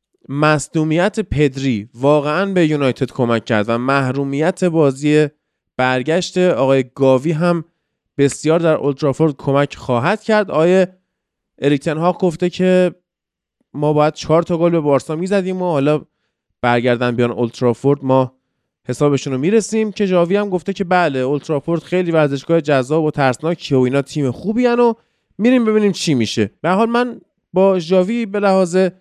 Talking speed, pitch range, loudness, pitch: 150 wpm, 135-185 Hz, -16 LUFS, 155 Hz